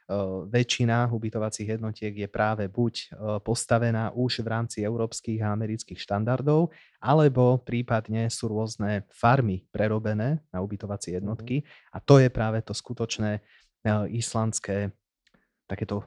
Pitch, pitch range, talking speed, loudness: 110 Hz, 105-120 Hz, 115 wpm, -27 LUFS